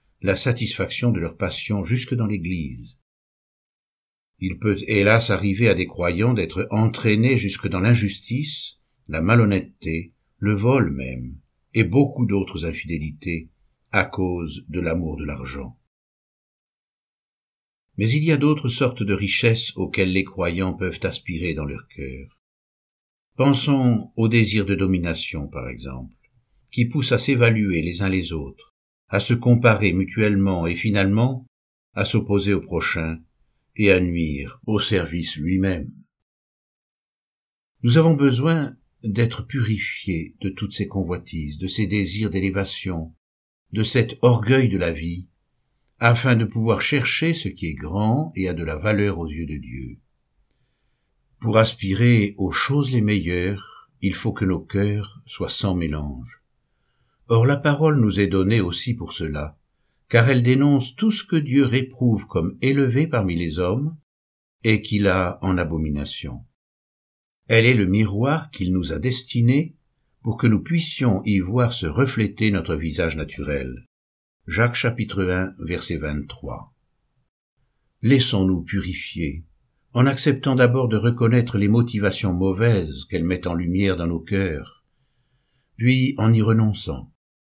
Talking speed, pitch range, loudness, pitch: 140 wpm, 85-120 Hz, -20 LUFS, 100 Hz